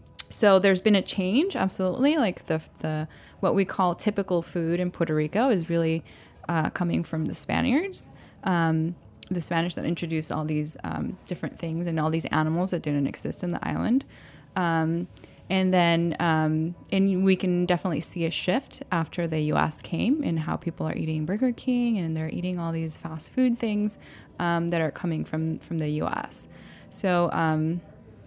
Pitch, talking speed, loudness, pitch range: 170 Hz, 180 wpm, -26 LUFS, 160-190 Hz